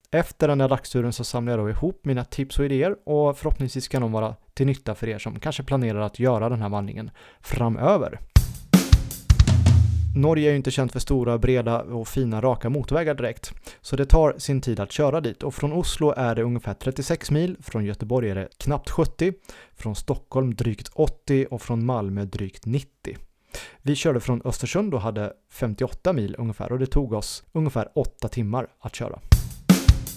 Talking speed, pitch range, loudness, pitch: 185 wpm, 110-140 Hz, -24 LUFS, 125 Hz